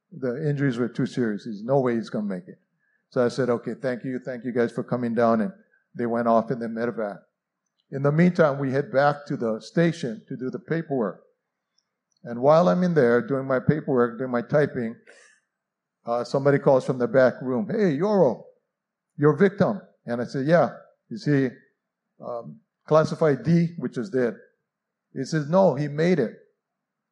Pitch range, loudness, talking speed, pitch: 125-180 Hz, -24 LUFS, 190 wpm, 140 Hz